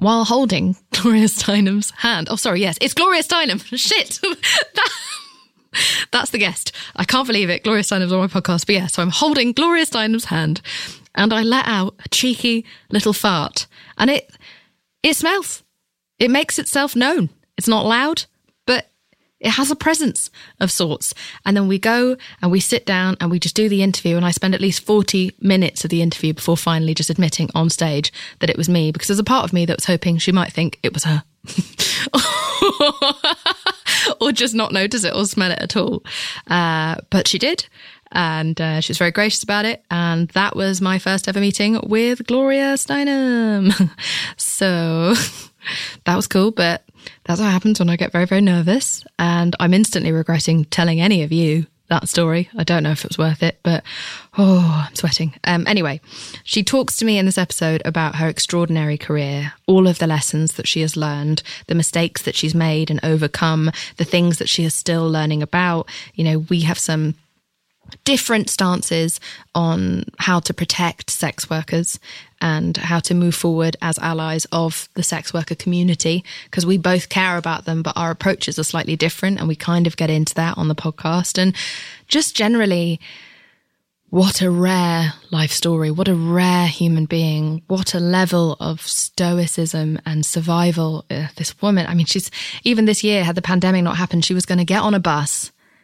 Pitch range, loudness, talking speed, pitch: 165-205 Hz, -18 LUFS, 185 wpm, 175 Hz